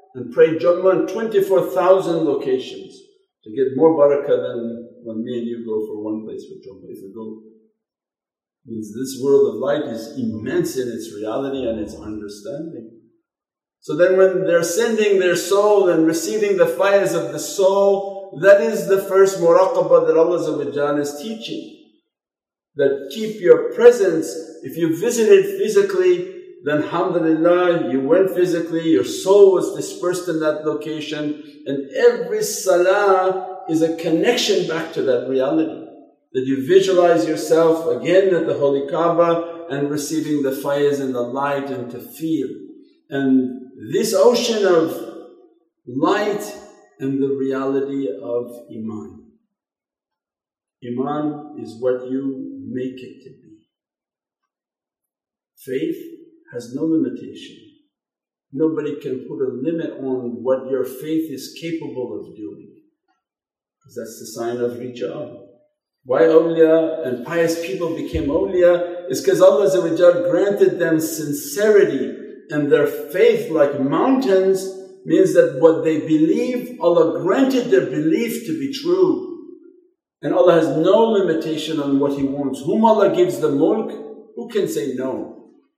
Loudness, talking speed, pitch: -18 LUFS, 140 wpm, 175 Hz